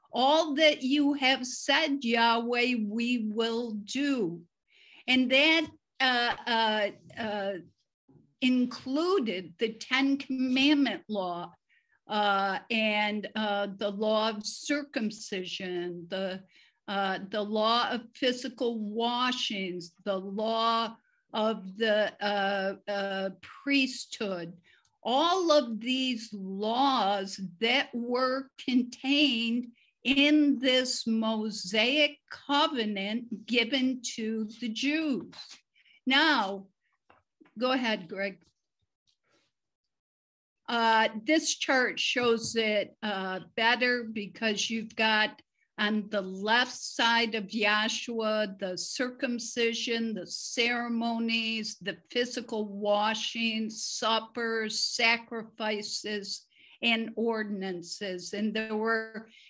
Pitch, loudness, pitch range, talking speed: 225 Hz, -29 LUFS, 210-255 Hz, 90 wpm